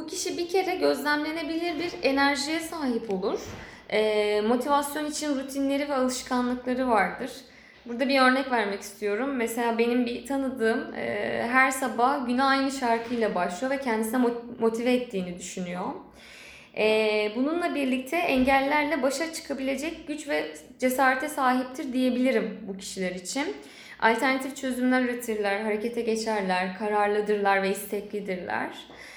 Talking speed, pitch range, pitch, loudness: 120 wpm, 215-275 Hz, 250 Hz, -26 LUFS